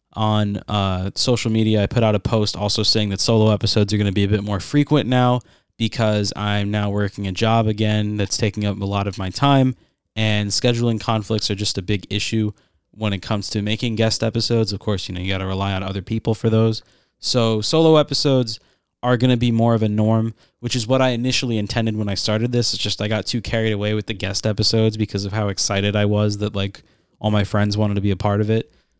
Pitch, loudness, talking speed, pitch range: 105 Hz, -20 LUFS, 240 wpm, 100-115 Hz